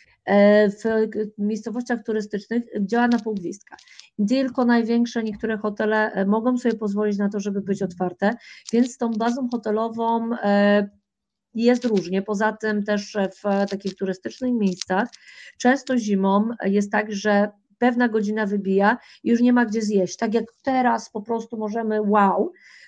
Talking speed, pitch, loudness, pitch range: 135 wpm, 215 Hz, -22 LUFS, 205-235 Hz